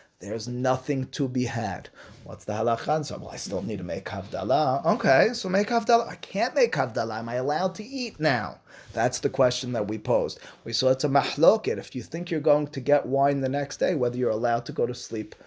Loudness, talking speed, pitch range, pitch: -26 LUFS, 230 wpm, 115-150 Hz, 130 Hz